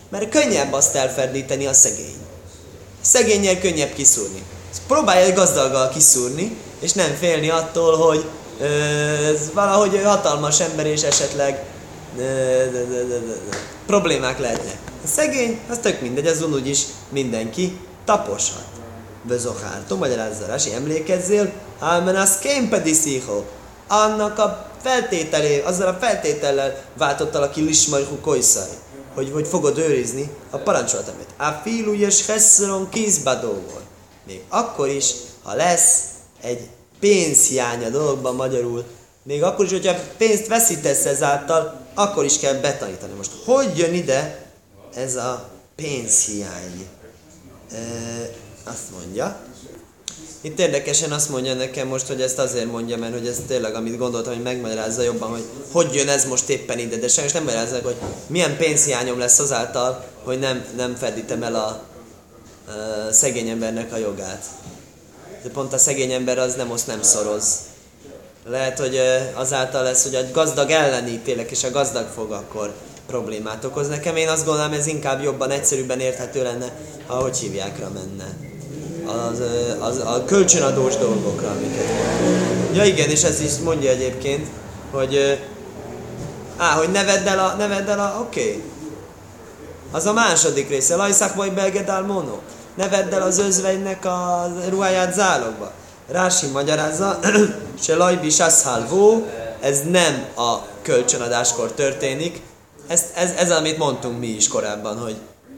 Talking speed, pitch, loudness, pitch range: 135 wpm, 140 Hz, -19 LUFS, 120-175 Hz